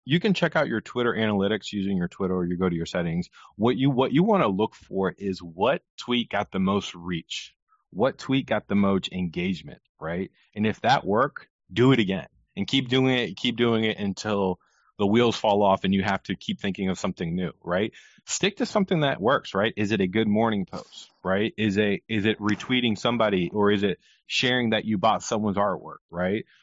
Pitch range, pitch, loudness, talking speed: 95-120 Hz, 105 Hz, -25 LUFS, 215 wpm